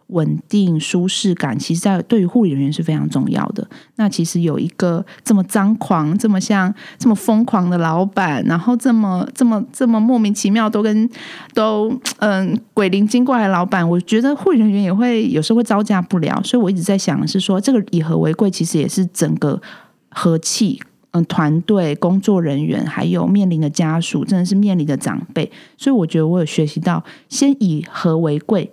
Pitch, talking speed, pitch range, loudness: 195 Hz, 290 characters per minute, 170-220 Hz, -16 LUFS